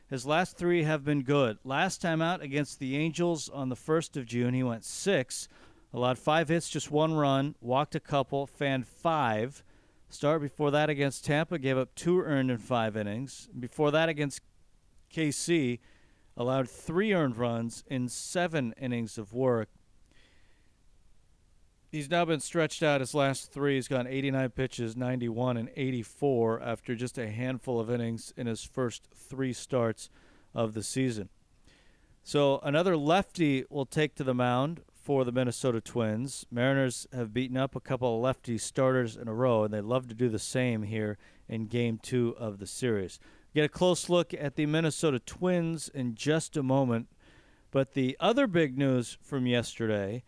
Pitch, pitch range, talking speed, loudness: 130 Hz, 115-150 Hz, 170 wpm, -30 LUFS